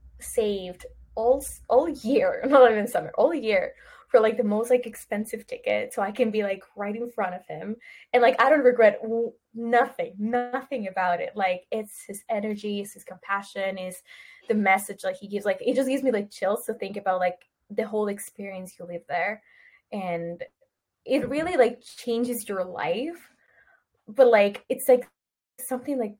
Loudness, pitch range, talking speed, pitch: -25 LUFS, 195-250 Hz, 180 wpm, 220 Hz